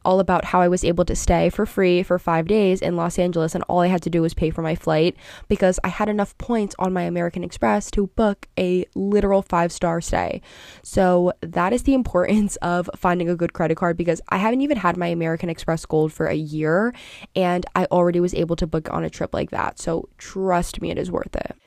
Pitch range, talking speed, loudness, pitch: 170-190 Hz, 235 wpm, -21 LUFS, 180 Hz